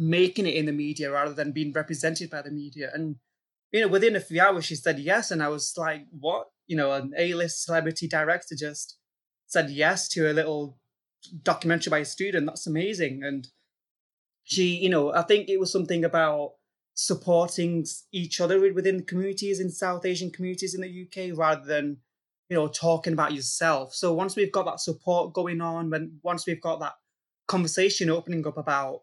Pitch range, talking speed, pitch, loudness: 150-180 Hz, 190 wpm, 165 Hz, -26 LUFS